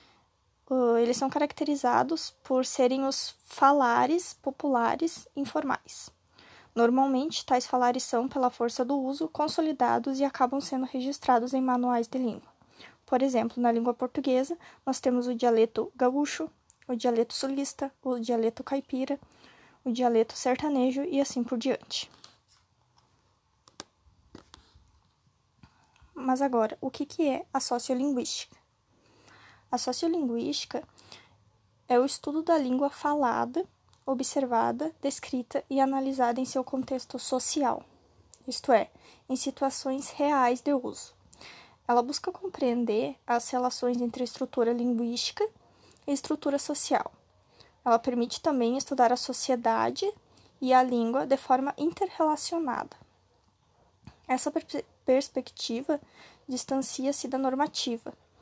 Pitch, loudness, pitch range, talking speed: 265 Hz, -28 LUFS, 250-280 Hz, 110 wpm